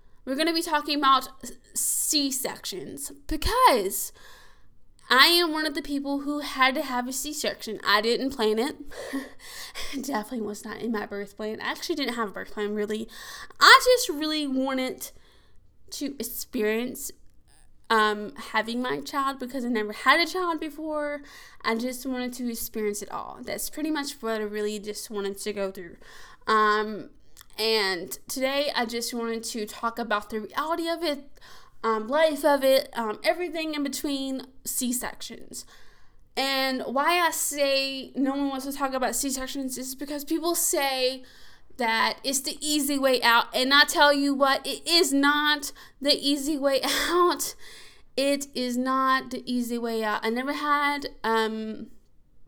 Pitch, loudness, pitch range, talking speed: 265 Hz, -25 LUFS, 225-295 Hz, 165 wpm